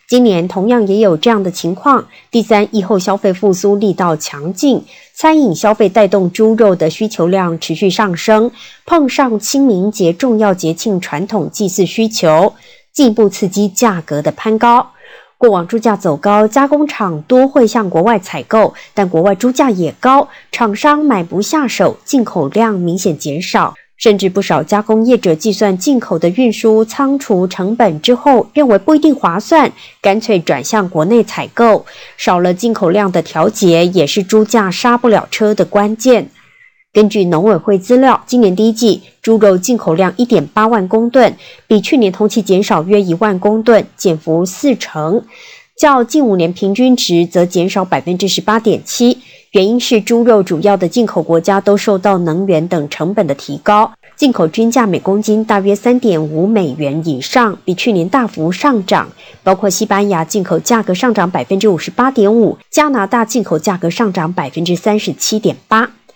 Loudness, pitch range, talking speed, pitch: -12 LUFS, 185-235 Hz, 265 characters per minute, 210 Hz